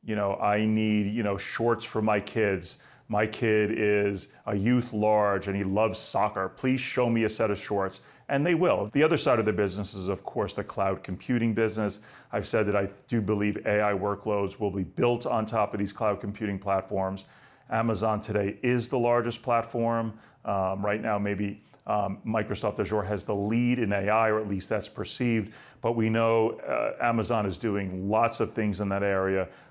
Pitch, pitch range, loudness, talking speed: 105 Hz, 100-115 Hz, -28 LUFS, 195 wpm